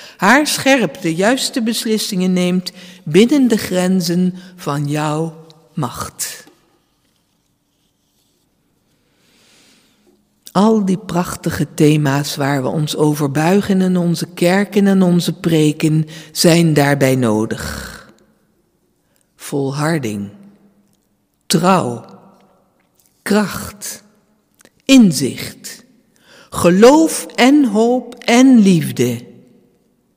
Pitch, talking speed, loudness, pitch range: 180 Hz, 80 wpm, -14 LUFS, 150-210 Hz